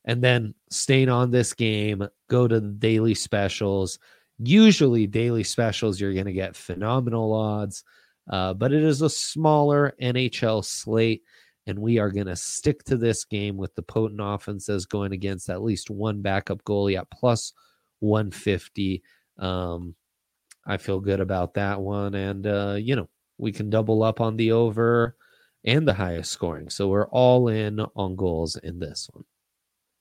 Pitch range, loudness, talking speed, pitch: 100-115 Hz, -24 LUFS, 165 wpm, 105 Hz